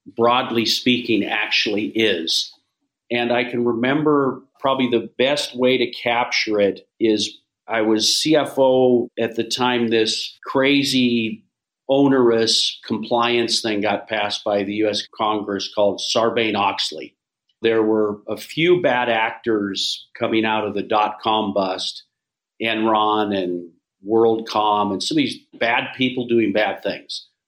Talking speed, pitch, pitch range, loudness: 135 wpm, 115 Hz, 105-125 Hz, -19 LUFS